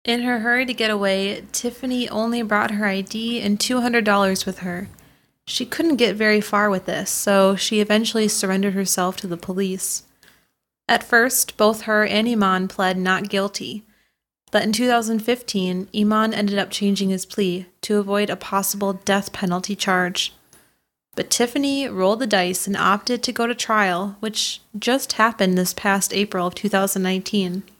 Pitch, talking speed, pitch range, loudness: 205 Hz, 160 wpm, 190-225 Hz, -20 LUFS